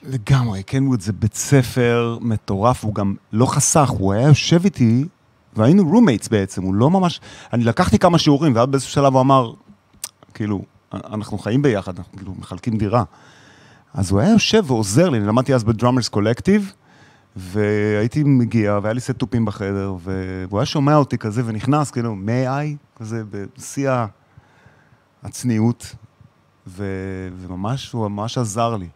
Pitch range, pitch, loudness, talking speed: 105-135 Hz, 115 Hz, -18 LUFS, 150 wpm